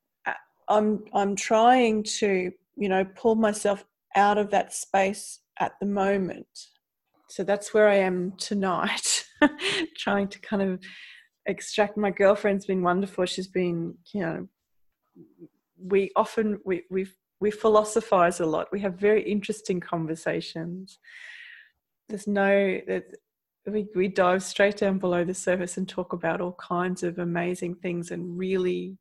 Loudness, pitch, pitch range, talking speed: -26 LUFS, 195 Hz, 185-210 Hz, 140 wpm